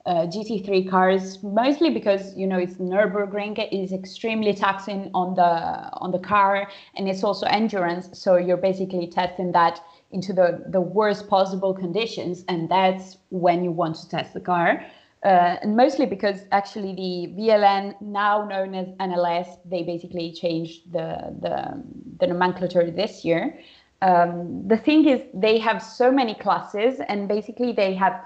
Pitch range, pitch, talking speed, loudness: 180-210 Hz, 190 Hz, 160 wpm, -23 LUFS